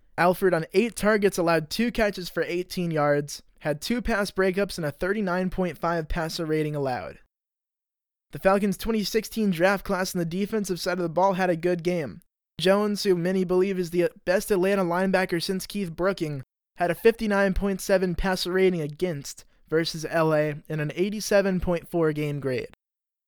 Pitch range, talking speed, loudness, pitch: 165-195 Hz, 155 wpm, -25 LUFS, 185 Hz